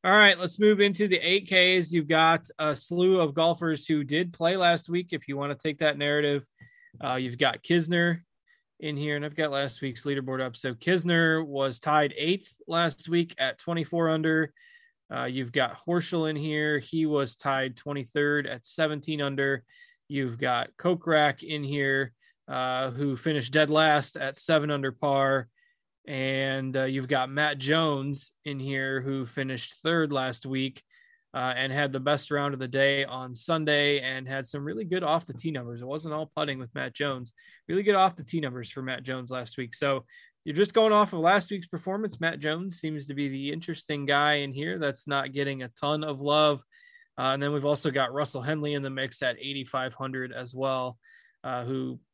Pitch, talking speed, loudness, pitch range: 145 Hz, 200 wpm, -27 LUFS, 135-165 Hz